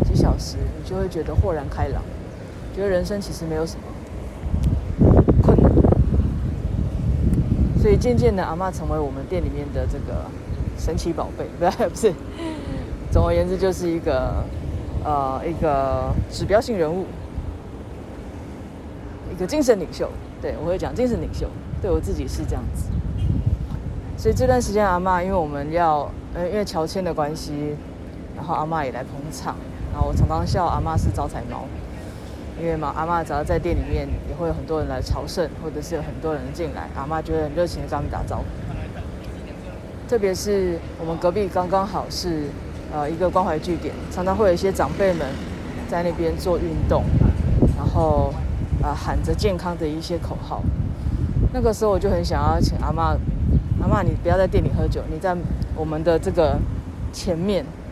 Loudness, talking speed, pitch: -23 LUFS, 255 characters per minute, 125 Hz